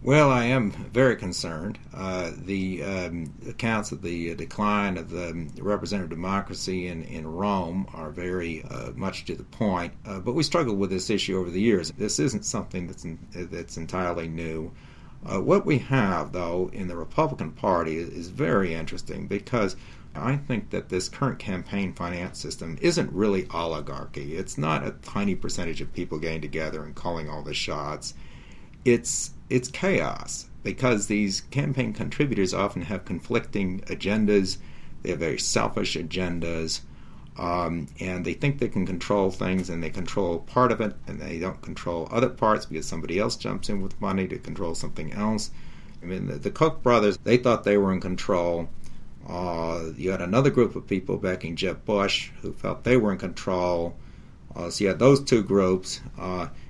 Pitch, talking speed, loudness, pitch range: 95 Hz, 175 wpm, -27 LUFS, 85-105 Hz